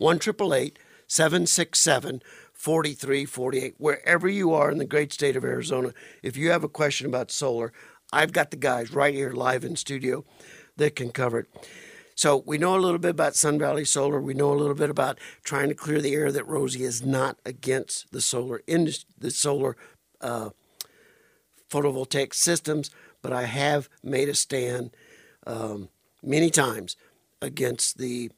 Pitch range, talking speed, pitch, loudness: 130-150 Hz, 160 wpm, 140 Hz, -25 LUFS